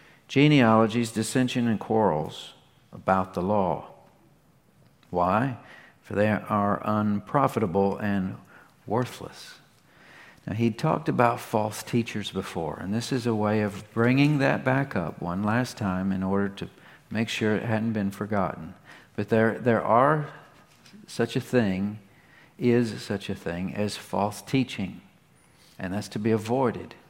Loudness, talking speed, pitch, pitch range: -26 LUFS, 135 wpm, 110 Hz, 100-125 Hz